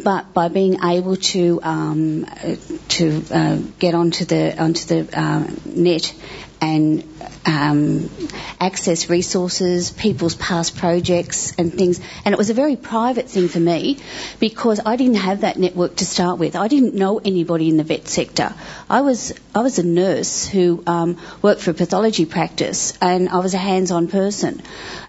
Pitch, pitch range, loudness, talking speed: 180 Hz, 170-195 Hz, -18 LUFS, 175 wpm